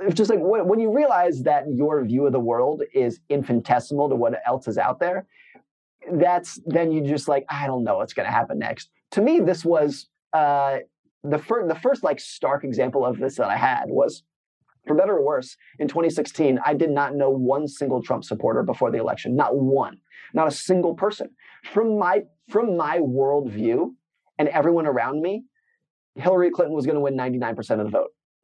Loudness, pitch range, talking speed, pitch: -22 LUFS, 140-180 Hz, 195 wpm, 150 Hz